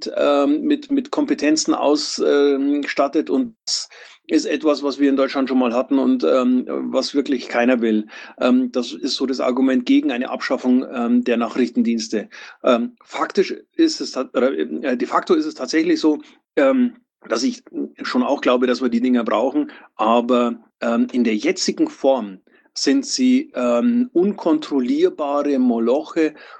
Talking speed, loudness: 155 wpm, -19 LUFS